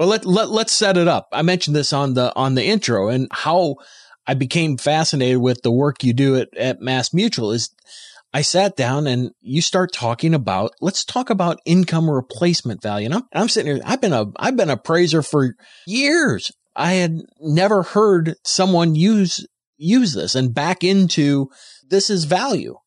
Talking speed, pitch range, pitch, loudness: 190 wpm, 135-190 Hz, 165 Hz, -18 LUFS